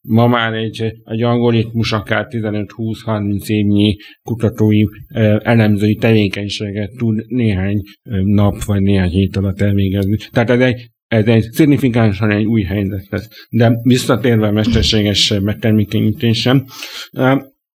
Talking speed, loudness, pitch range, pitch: 120 wpm, -15 LUFS, 105-115 Hz, 110 Hz